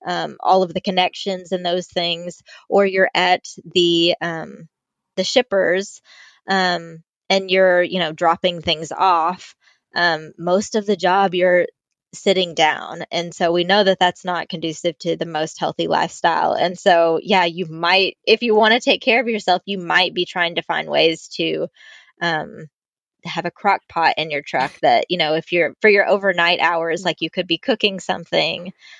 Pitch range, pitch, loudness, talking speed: 170-190 Hz, 180 Hz, -18 LUFS, 180 wpm